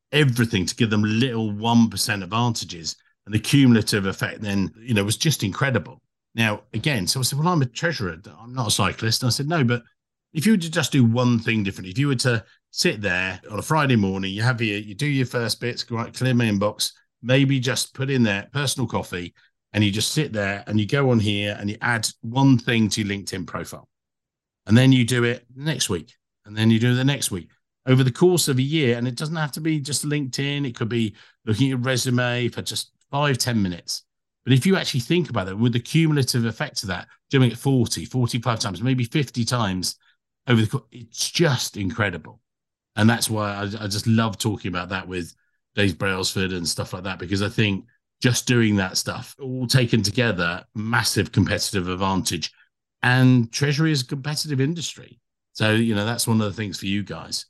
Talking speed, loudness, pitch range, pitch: 220 wpm, -22 LUFS, 105-130 Hz, 115 Hz